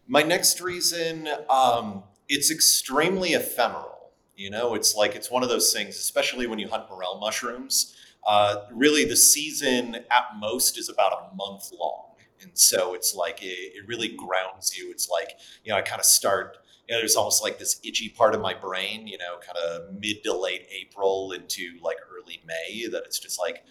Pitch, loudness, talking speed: 150 Hz, -23 LUFS, 190 wpm